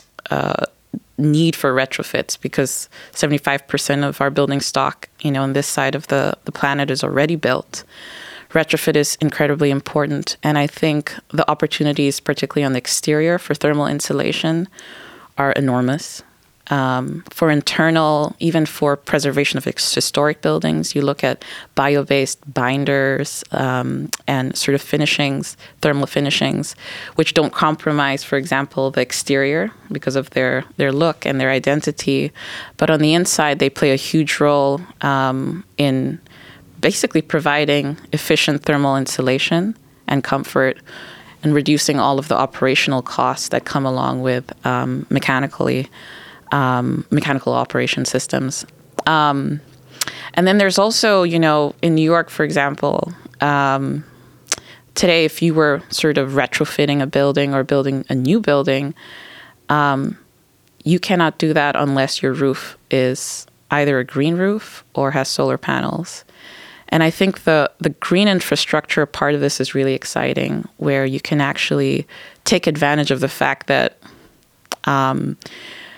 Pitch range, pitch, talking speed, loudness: 135-155 Hz, 145 Hz, 140 wpm, -18 LUFS